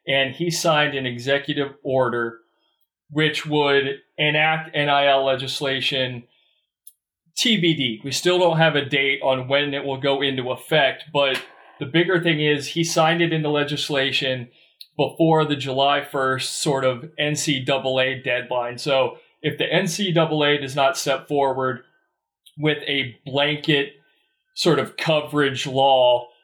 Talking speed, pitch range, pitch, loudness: 130 wpm, 135-155 Hz, 145 Hz, -21 LUFS